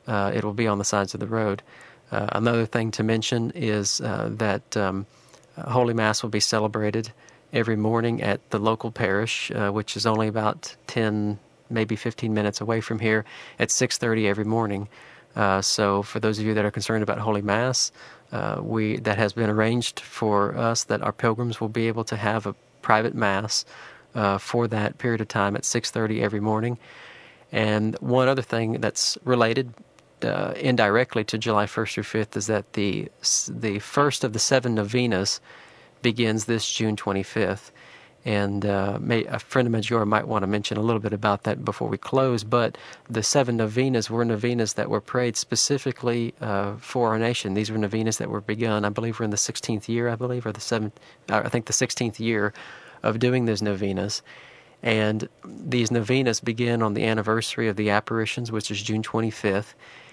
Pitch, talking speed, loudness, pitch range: 110 Hz, 190 wpm, -24 LUFS, 105-115 Hz